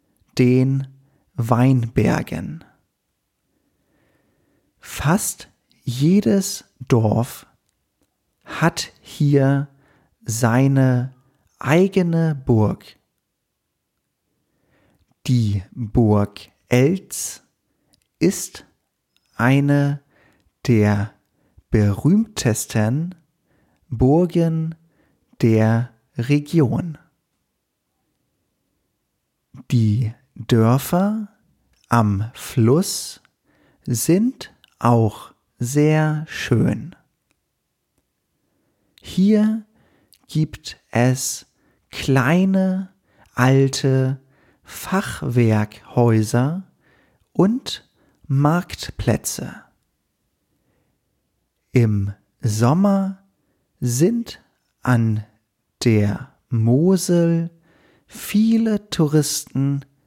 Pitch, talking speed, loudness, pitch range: 135 Hz, 45 wpm, -19 LUFS, 115-165 Hz